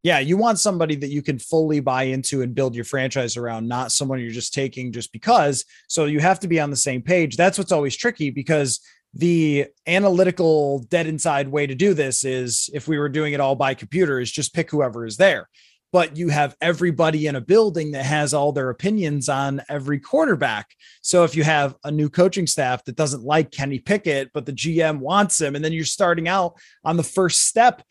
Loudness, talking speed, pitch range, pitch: -20 LUFS, 215 wpm, 135-170 Hz, 150 Hz